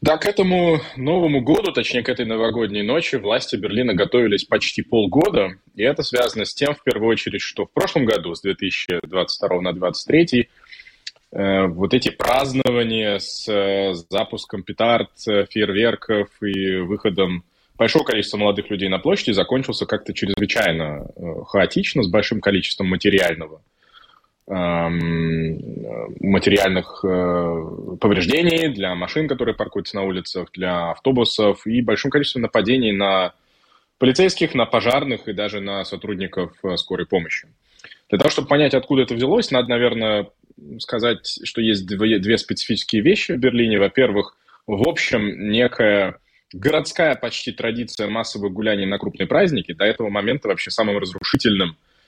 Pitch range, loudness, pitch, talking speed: 95-120 Hz, -20 LUFS, 105 Hz, 130 wpm